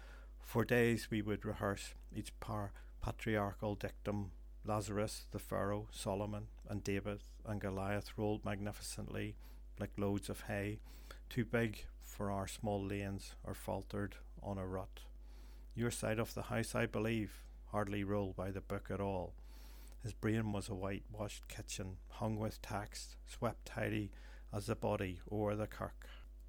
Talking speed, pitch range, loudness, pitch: 145 wpm, 95-105 Hz, -42 LUFS, 100 Hz